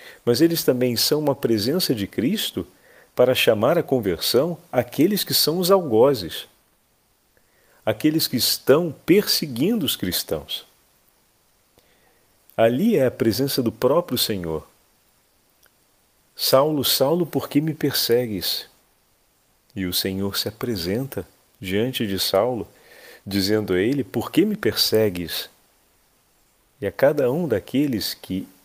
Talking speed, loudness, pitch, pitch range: 120 wpm, -21 LUFS, 125 Hz, 100-145 Hz